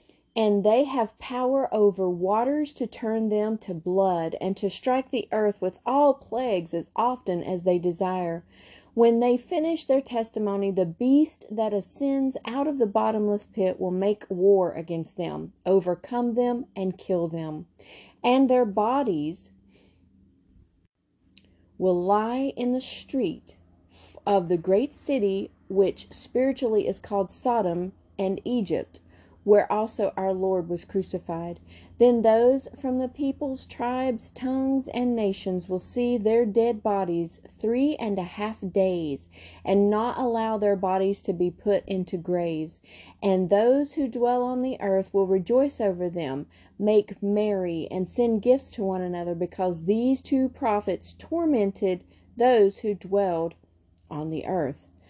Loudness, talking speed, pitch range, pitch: -25 LUFS, 145 wpm, 180-245 Hz, 200 Hz